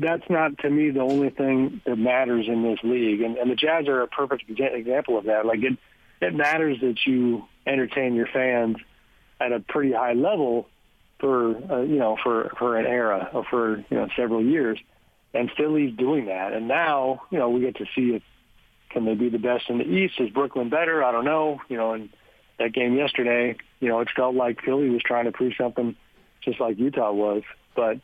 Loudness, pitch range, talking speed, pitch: -24 LUFS, 115-135 Hz, 210 wpm, 125 Hz